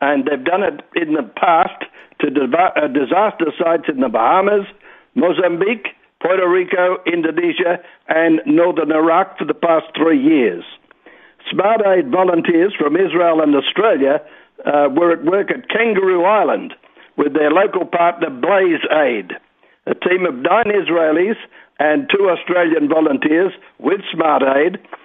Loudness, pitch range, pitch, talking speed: -15 LUFS, 160-195 Hz, 175 Hz, 135 wpm